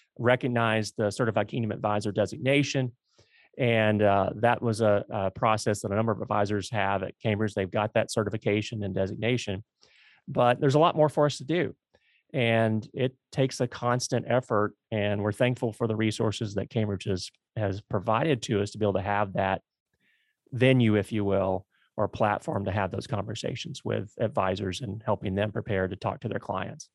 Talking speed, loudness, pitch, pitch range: 185 wpm, -28 LUFS, 110 Hz, 100-120 Hz